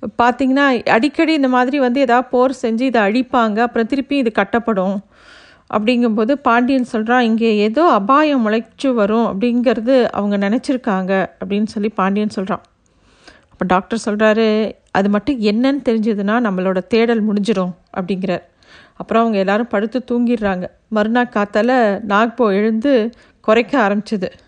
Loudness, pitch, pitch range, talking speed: -16 LUFS, 230 Hz, 205-250 Hz, 125 wpm